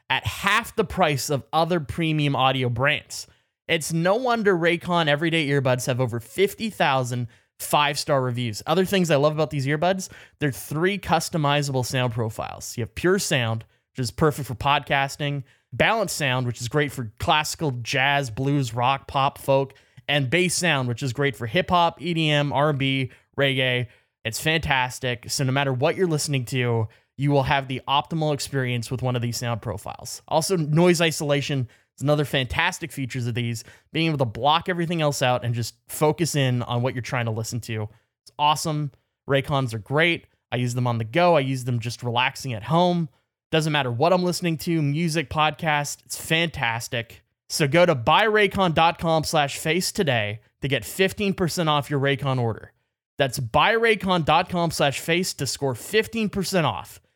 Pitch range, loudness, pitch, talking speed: 125-165 Hz, -23 LUFS, 140 Hz, 170 wpm